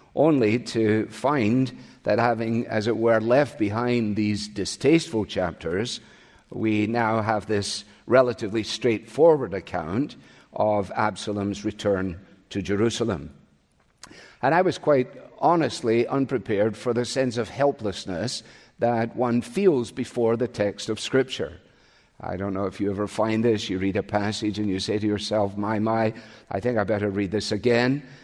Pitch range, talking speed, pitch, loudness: 105-120 Hz, 150 wpm, 110 Hz, -24 LUFS